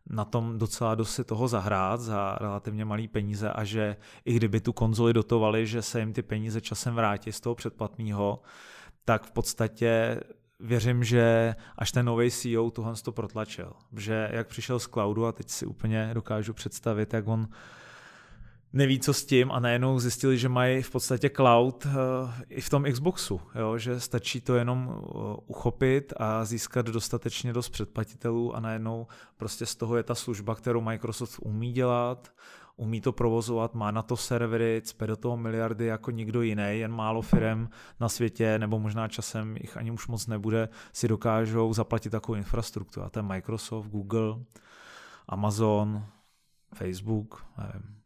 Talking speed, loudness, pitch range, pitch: 165 wpm, -29 LUFS, 110-120 Hz, 115 Hz